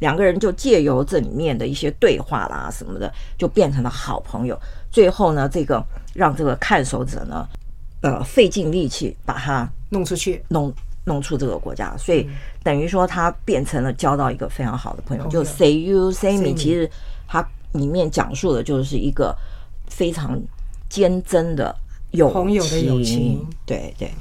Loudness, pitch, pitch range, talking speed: -20 LUFS, 150 Hz, 135-180 Hz, 265 characters per minute